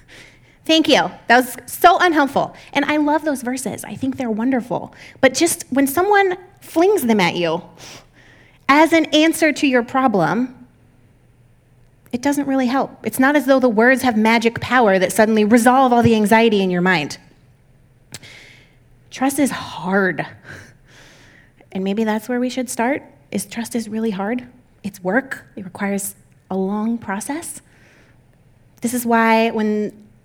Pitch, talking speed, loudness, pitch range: 225 Hz, 155 wpm, -17 LUFS, 175-265 Hz